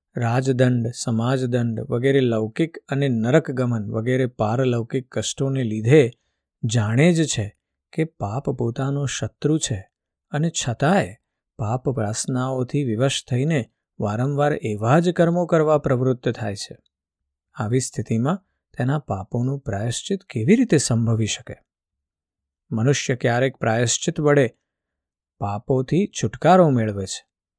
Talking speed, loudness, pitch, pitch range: 105 wpm, -22 LUFS, 125 Hz, 110-140 Hz